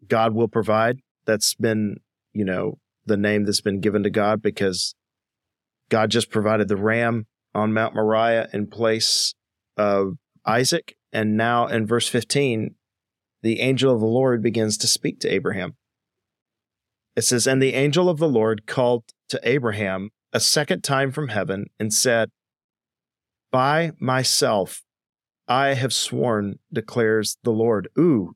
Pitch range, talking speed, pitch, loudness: 105-120 Hz, 145 wpm, 110 Hz, -21 LUFS